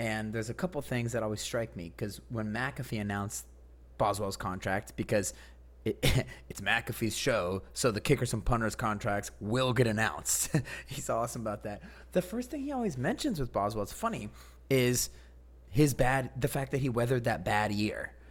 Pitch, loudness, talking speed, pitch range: 110 Hz, -32 LUFS, 175 wpm, 100-130 Hz